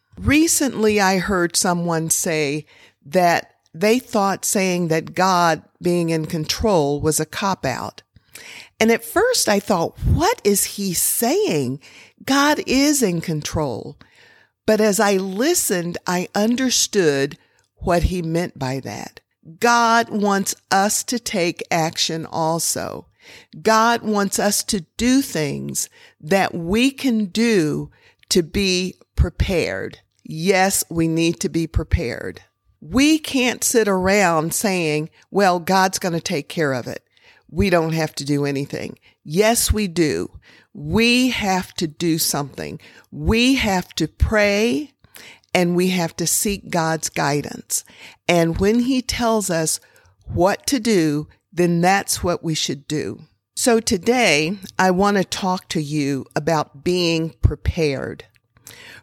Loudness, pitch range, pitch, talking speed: -19 LUFS, 160-215 Hz, 185 Hz, 135 wpm